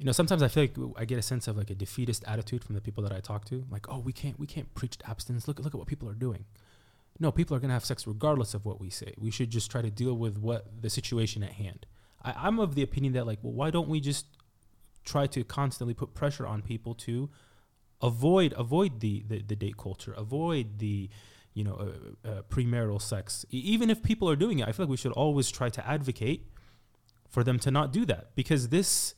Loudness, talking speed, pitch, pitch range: -31 LUFS, 245 wpm, 120 Hz, 105-140 Hz